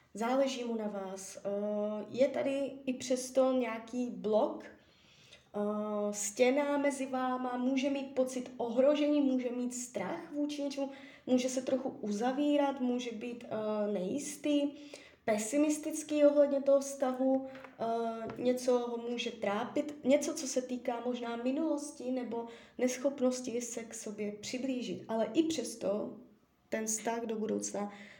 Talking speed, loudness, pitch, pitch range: 120 wpm, -34 LUFS, 255 Hz, 225-275 Hz